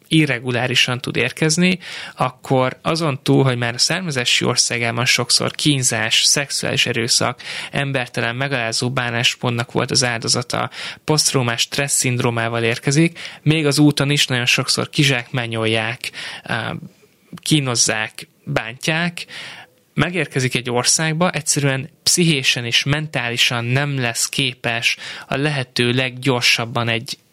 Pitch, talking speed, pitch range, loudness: 130 Hz, 105 wpm, 120-150 Hz, -17 LUFS